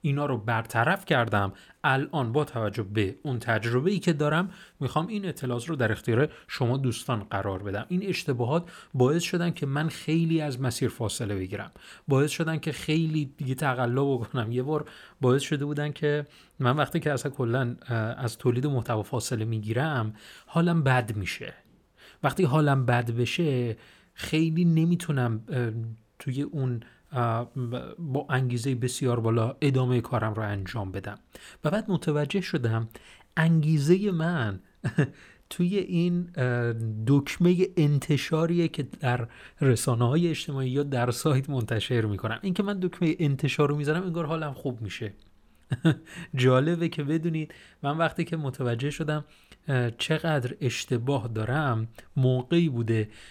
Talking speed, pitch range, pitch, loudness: 135 wpm, 120-160 Hz, 135 Hz, -27 LUFS